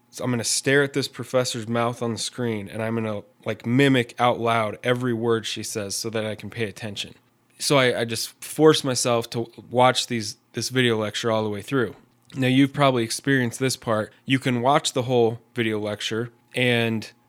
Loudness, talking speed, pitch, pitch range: -23 LUFS, 200 wpm, 120 Hz, 115-125 Hz